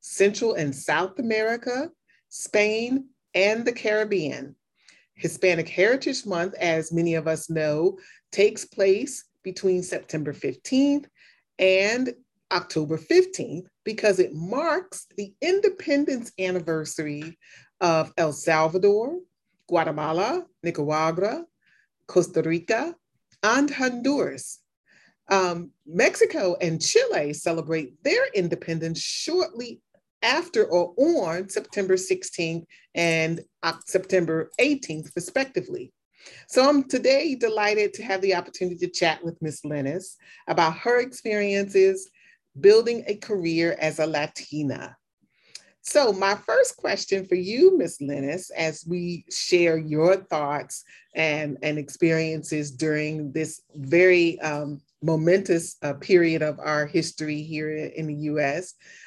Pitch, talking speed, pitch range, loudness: 180 Hz, 110 wpm, 160-235 Hz, -24 LUFS